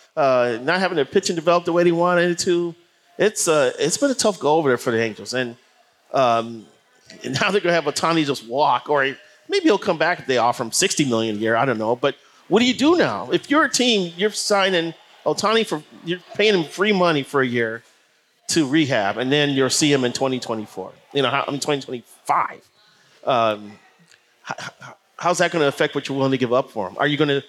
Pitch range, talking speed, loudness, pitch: 125-180 Hz, 230 wpm, -20 LUFS, 150 Hz